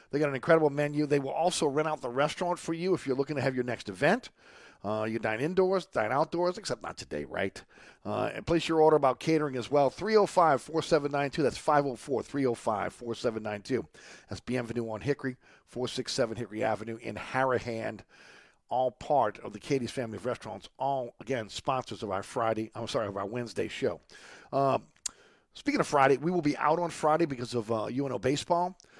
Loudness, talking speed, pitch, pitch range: -30 LUFS, 185 wpm, 135 Hz, 115-155 Hz